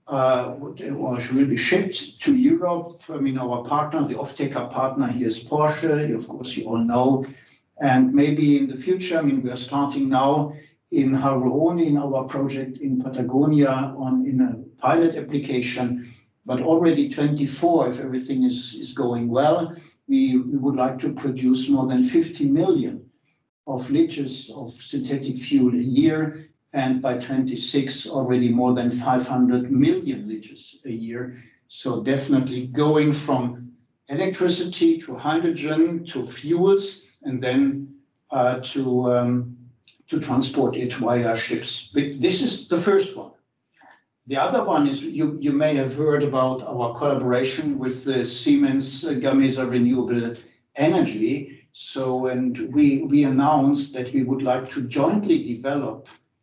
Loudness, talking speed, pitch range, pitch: -22 LUFS, 145 wpm, 125-150 Hz, 135 Hz